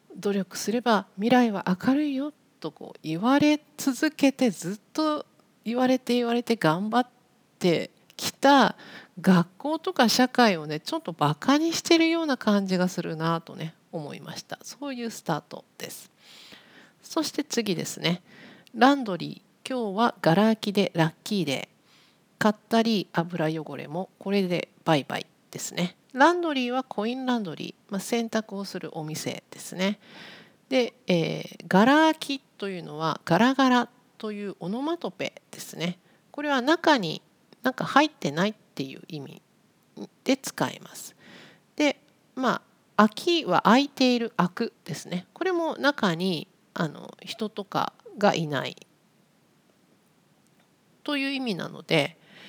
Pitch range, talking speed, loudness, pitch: 185-270 Hz, 275 characters per minute, -26 LUFS, 225 Hz